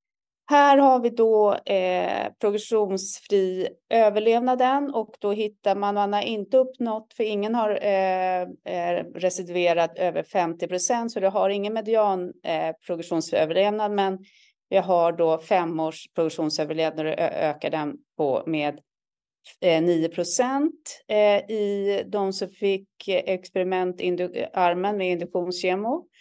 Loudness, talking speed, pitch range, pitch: -24 LUFS, 120 wpm, 175-215 Hz, 195 Hz